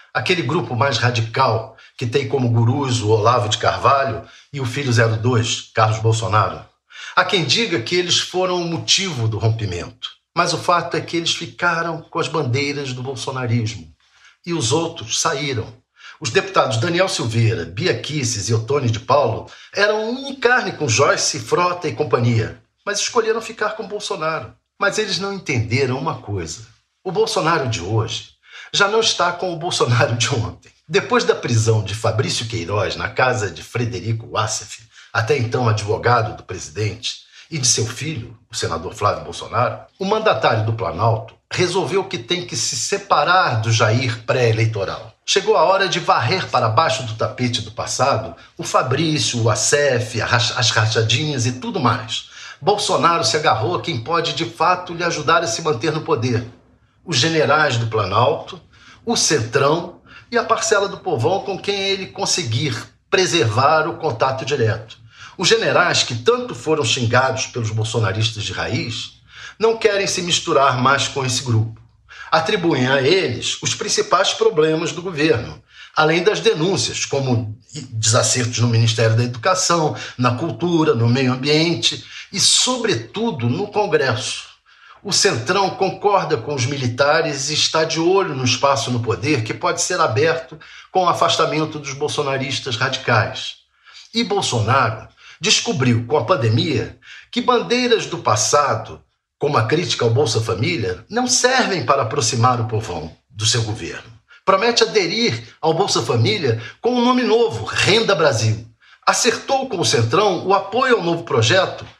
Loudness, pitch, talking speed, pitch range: -18 LUFS, 135 Hz, 155 wpm, 115-175 Hz